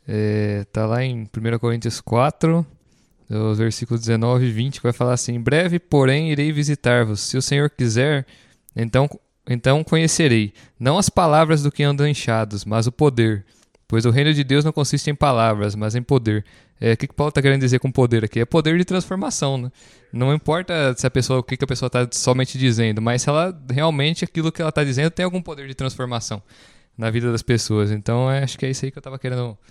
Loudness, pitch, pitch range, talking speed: -20 LUFS, 130 Hz, 115-145 Hz, 210 wpm